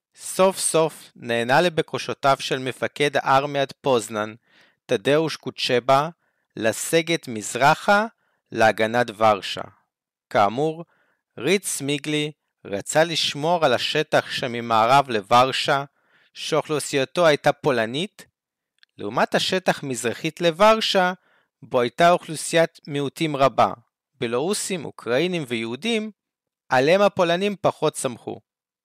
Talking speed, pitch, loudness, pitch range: 85 wpm, 145 Hz, -21 LUFS, 125-175 Hz